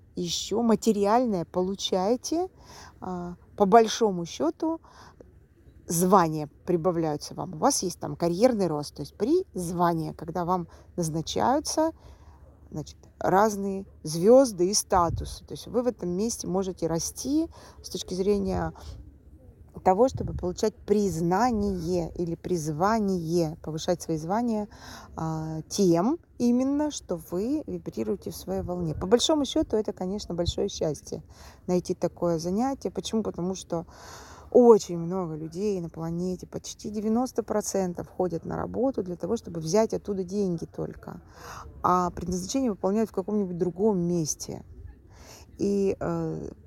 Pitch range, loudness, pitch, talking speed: 170-220 Hz, -27 LUFS, 185 Hz, 125 wpm